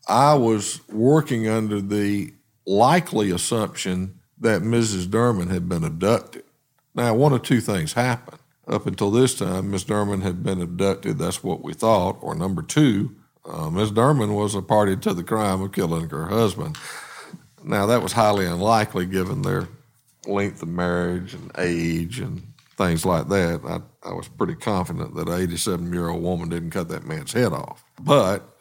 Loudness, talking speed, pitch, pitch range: -22 LUFS, 170 wpm, 100 Hz, 90-115 Hz